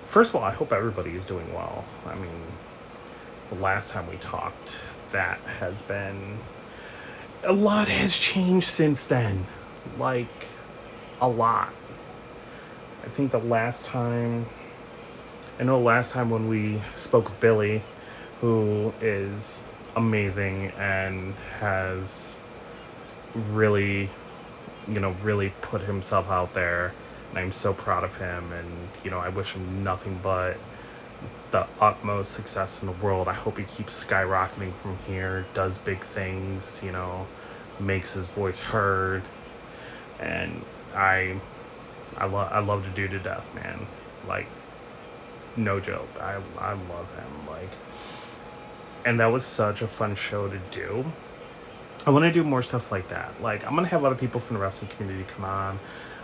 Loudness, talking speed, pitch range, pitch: -27 LUFS, 150 wpm, 95-115 Hz, 100 Hz